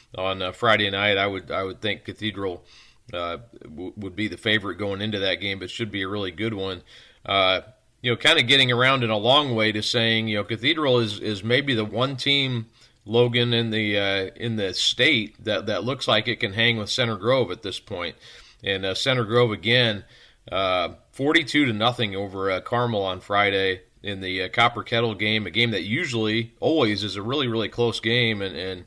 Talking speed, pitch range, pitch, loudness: 210 wpm, 100-120 Hz, 110 Hz, -22 LUFS